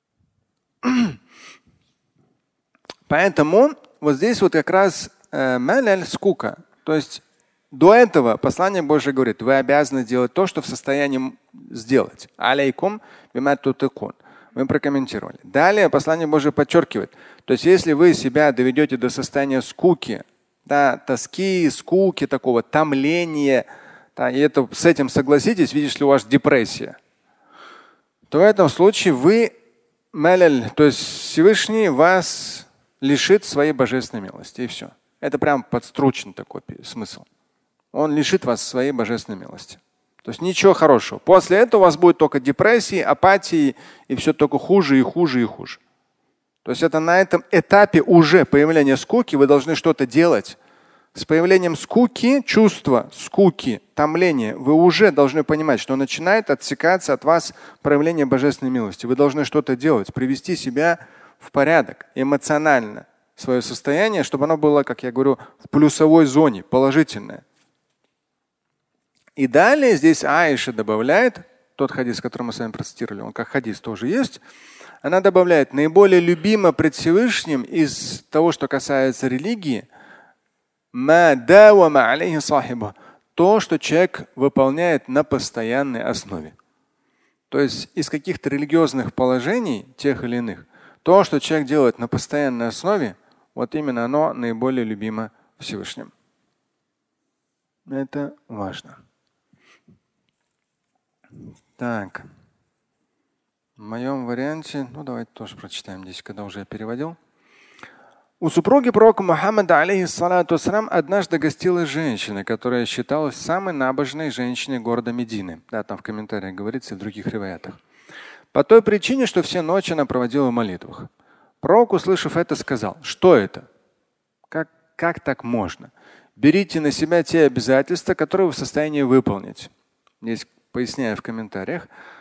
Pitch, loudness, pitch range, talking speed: 150 Hz, -18 LUFS, 130-175 Hz, 130 wpm